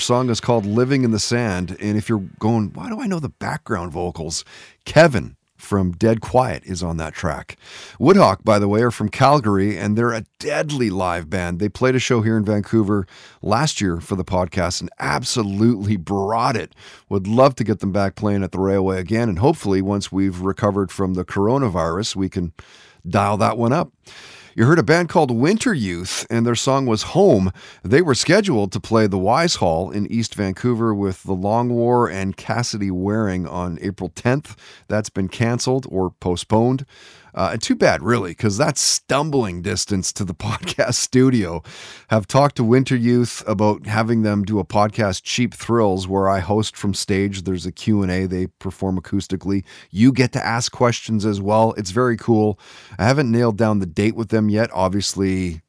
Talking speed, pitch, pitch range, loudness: 190 wpm, 105 Hz, 95-115 Hz, -19 LUFS